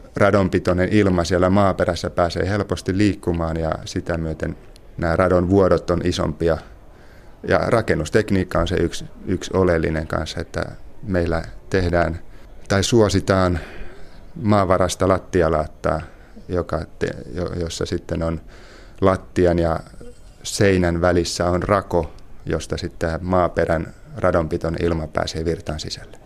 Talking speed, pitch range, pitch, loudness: 105 wpm, 85-95 Hz, 90 Hz, -21 LUFS